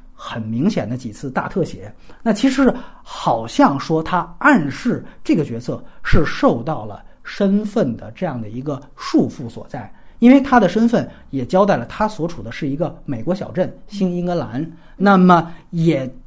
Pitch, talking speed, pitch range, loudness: 175 Hz, 245 characters per minute, 140-205 Hz, -18 LUFS